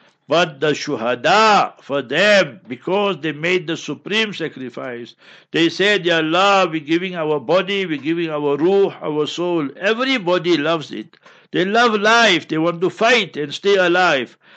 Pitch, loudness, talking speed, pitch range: 170 Hz, -17 LUFS, 155 wpm, 150-195 Hz